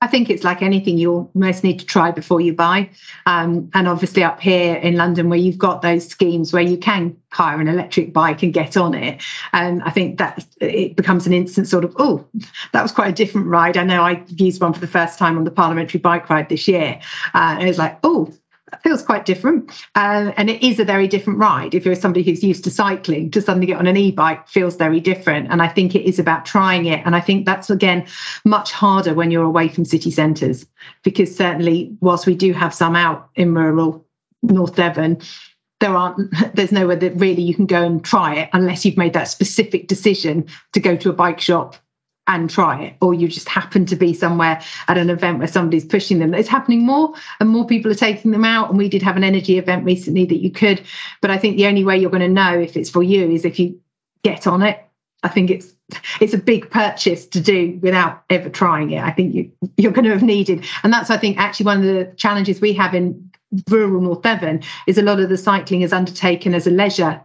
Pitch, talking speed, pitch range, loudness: 185 Hz, 235 wpm, 170-200 Hz, -16 LUFS